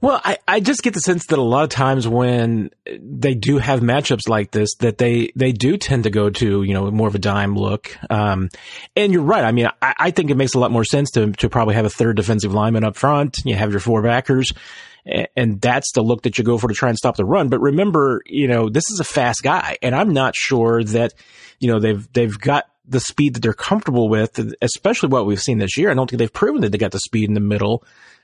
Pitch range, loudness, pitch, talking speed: 110-135 Hz, -18 LUFS, 120 Hz, 265 wpm